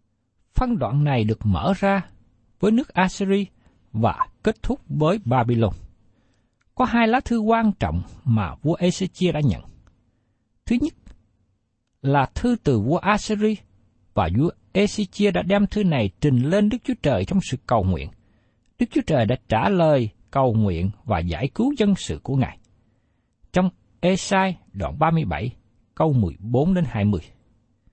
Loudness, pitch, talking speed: -22 LUFS, 130 Hz, 155 wpm